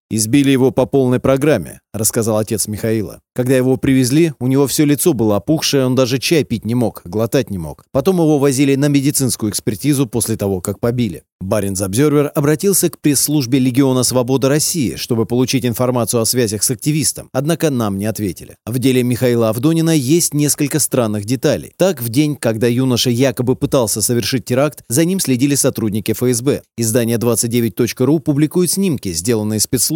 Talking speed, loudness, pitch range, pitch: 165 wpm, -15 LUFS, 115-145 Hz, 130 Hz